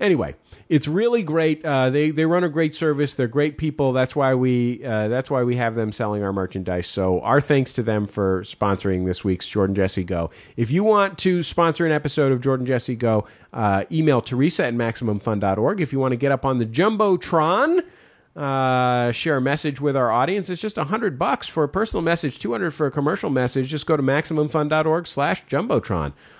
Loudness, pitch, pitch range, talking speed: -21 LUFS, 140 Hz, 115-160 Hz, 200 wpm